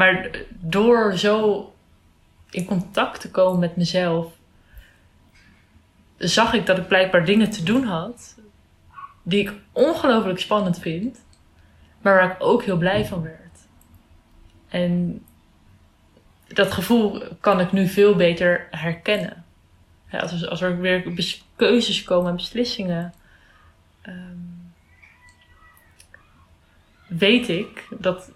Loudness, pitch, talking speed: -21 LUFS, 175 Hz, 105 wpm